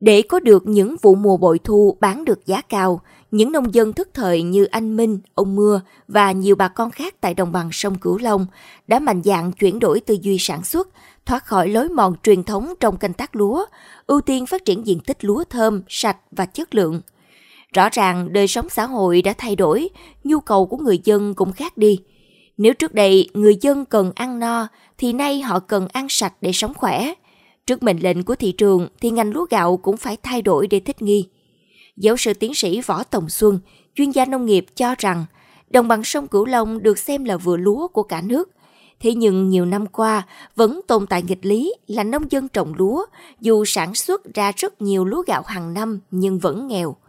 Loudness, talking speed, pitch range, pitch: -18 LUFS, 215 wpm, 190-240 Hz, 210 Hz